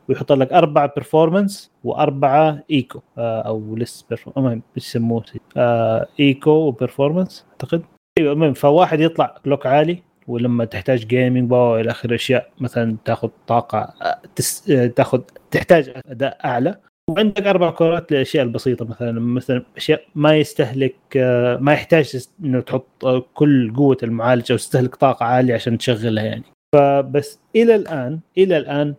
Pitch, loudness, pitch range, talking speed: 135 Hz, -18 LUFS, 120-155 Hz, 130 wpm